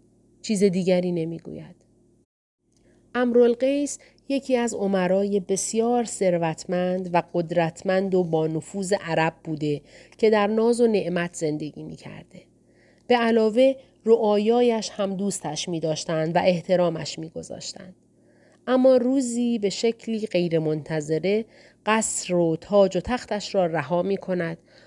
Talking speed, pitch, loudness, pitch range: 105 wpm, 190 Hz, -23 LUFS, 170-225 Hz